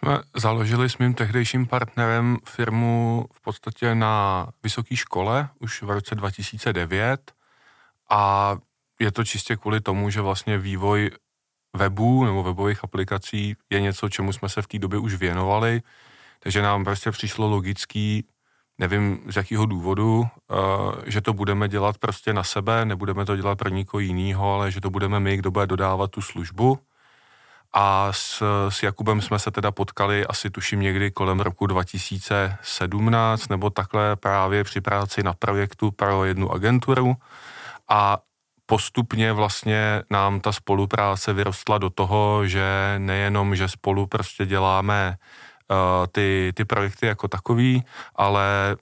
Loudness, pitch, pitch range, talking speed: -23 LUFS, 100 Hz, 100-110 Hz, 145 wpm